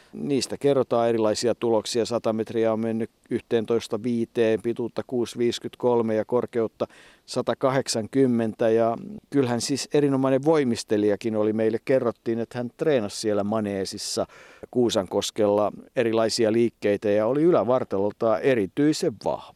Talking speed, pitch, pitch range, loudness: 105 wpm, 115 Hz, 110-120 Hz, -24 LUFS